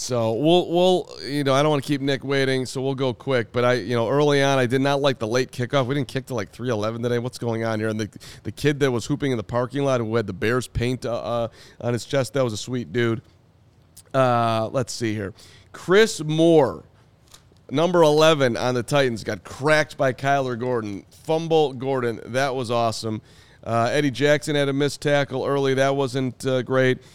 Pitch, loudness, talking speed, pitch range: 130 Hz, -22 LUFS, 220 wpm, 120-140 Hz